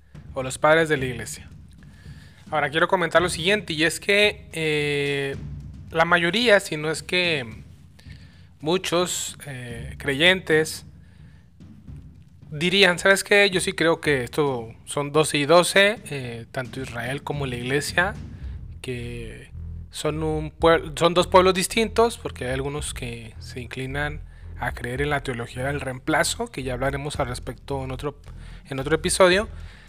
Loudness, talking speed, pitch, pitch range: -22 LUFS, 145 wpm, 145 Hz, 115-165 Hz